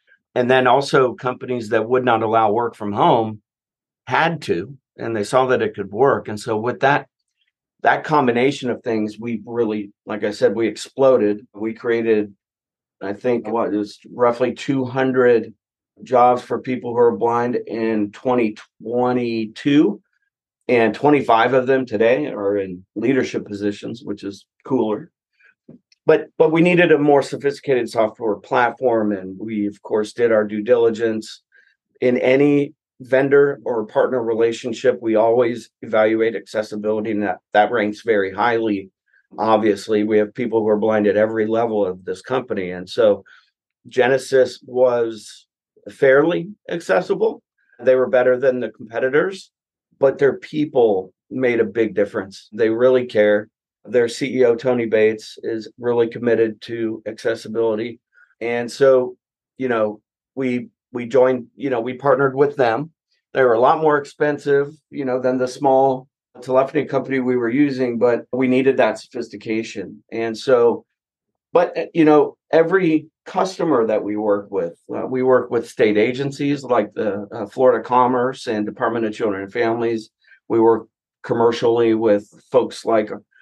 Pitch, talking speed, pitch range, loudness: 120 Hz, 150 wpm, 110-130 Hz, -19 LUFS